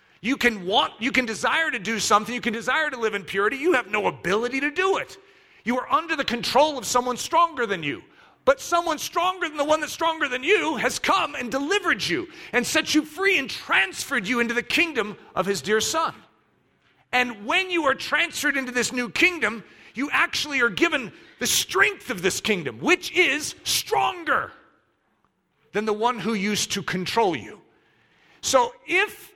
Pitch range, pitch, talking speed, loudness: 230-335 Hz, 275 Hz, 190 wpm, -23 LUFS